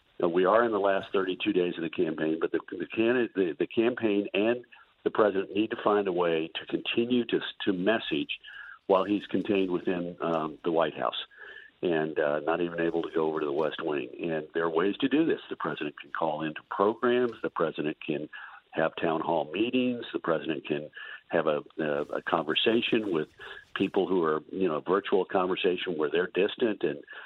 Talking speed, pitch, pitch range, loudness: 195 wpm, 95 Hz, 85-115 Hz, -29 LUFS